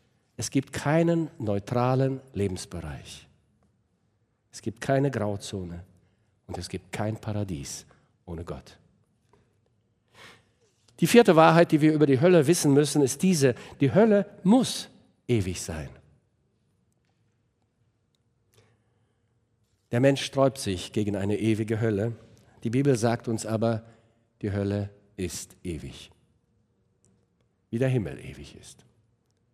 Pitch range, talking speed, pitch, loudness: 105-135 Hz, 110 wpm, 115 Hz, -25 LUFS